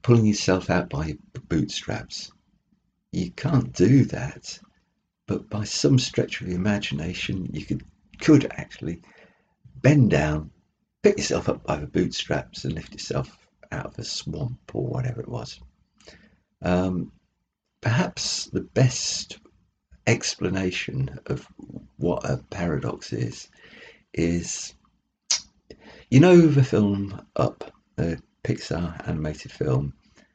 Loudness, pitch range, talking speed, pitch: -24 LUFS, 90-130 Hz, 115 wpm, 105 Hz